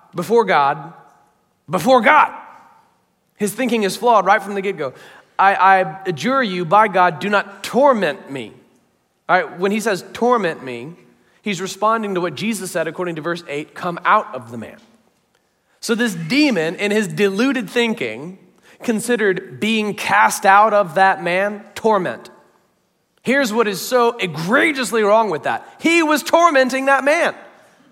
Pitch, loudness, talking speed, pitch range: 205 Hz, -17 LUFS, 155 wpm, 185-240 Hz